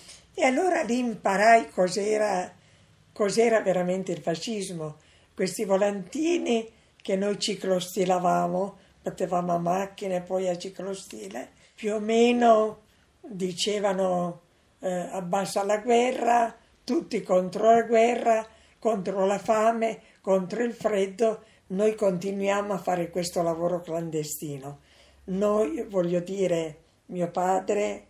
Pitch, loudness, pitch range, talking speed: 195 Hz, -26 LUFS, 180-220 Hz, 110 wpm